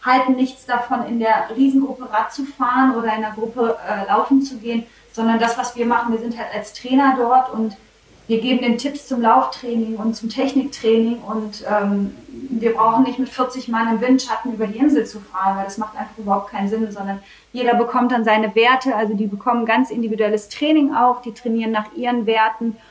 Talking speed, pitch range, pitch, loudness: 205 wpm, 220-255 Hz, 230 Hz, -19 LUFS